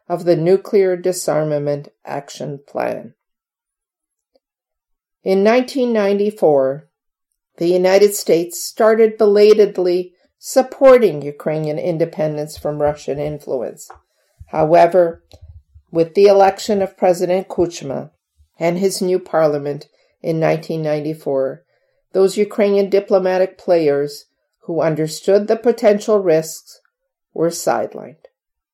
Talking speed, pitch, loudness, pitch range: 90 wpm, 180 Hz, -16 LUFS, 155-205 Hz